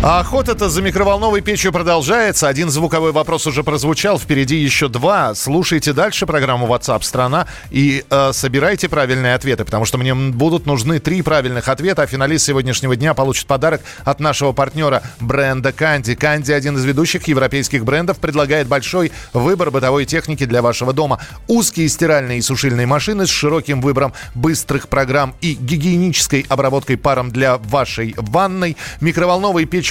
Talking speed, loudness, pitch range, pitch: 155 wpm, -15 LUFS, 135-165 Hz, 145 Hz